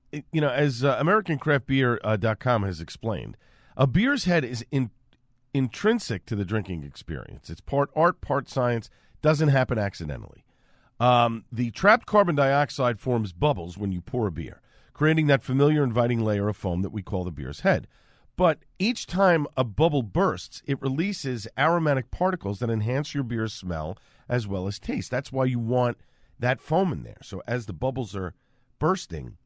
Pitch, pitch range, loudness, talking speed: 125 Hz, 110-145 Hz, -25 LUFS, 170 wpm